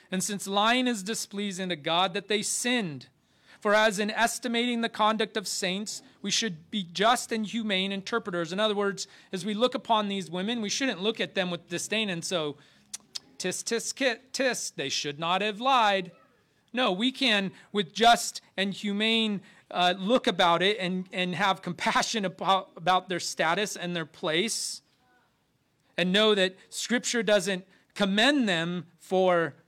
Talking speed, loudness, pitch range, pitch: 165 wpm, -27 LUFS, 180-225 Hz, 200 Hz